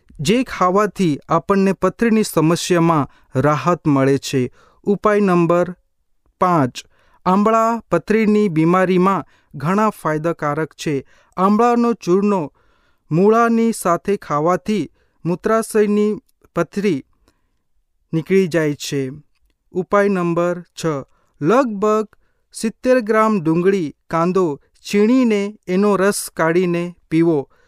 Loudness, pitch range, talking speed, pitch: -17 LUFS, 160-210 Hz, 85 wpm, 180 Hz